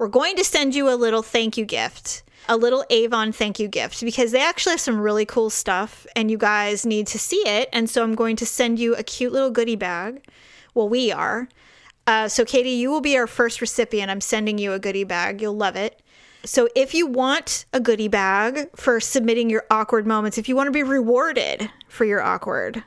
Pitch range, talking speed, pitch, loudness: 220-255 Hz, 225 wpm, 235 Hz, -21 LUFS